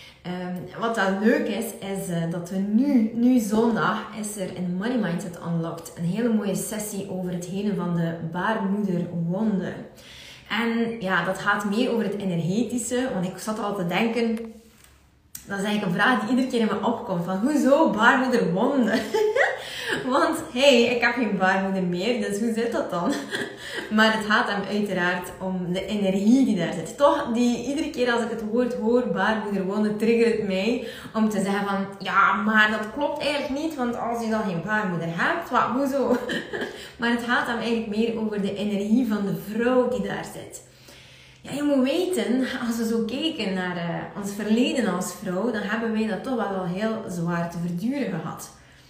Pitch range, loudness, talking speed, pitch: 190-240 Hz, -24 LUFS, 190 wpm, 215 Hz